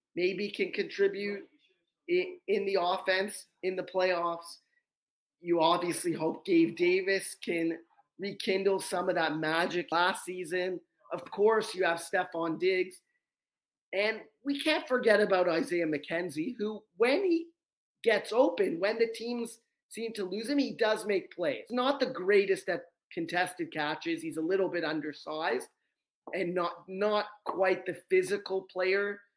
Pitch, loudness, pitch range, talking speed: 195 Hz, -31 LUFS, 175-250 Hz, 145 wpm